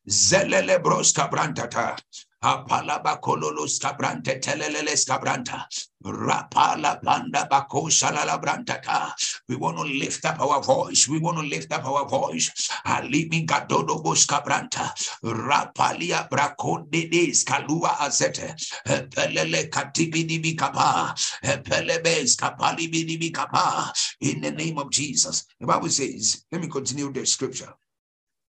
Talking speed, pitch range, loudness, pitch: 100 wpm, 135-165 Hz, -23 LUFS, 155 Hz